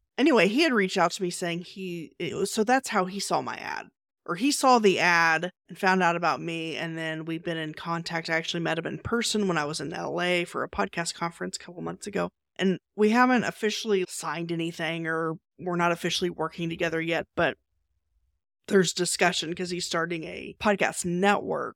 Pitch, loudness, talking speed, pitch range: 170 Hz, -26 LUFS, 205 wpm, 165-190 Hz